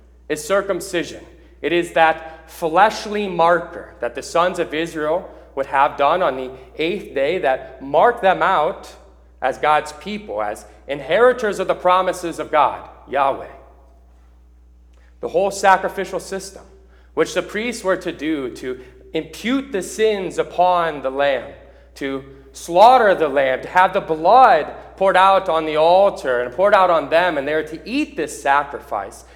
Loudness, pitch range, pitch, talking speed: -18 LUFS, 135-190 Hz, 165 Hz, 155 wpm